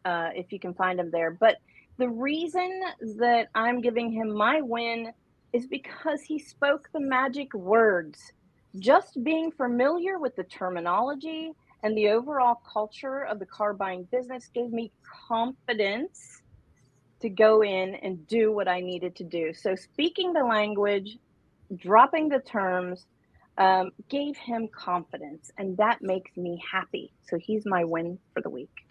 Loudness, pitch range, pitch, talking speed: -27 LUFS, 185-260 Hz, 220 Hz, 155 wpm